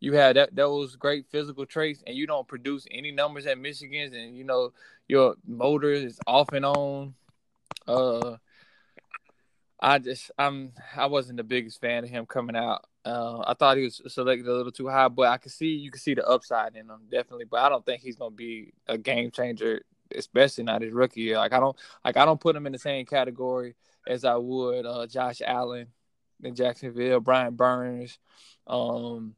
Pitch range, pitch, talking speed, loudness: 120-140 Hz, 125 Hz, 200 wpm, -26 LUFS